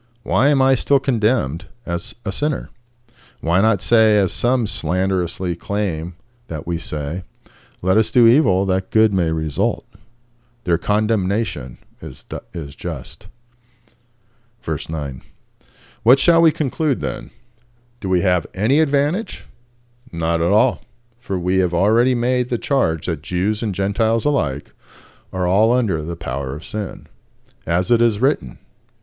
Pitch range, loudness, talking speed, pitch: 90-120 Hz, -19 LUFS, 145 wpm, 110 Hz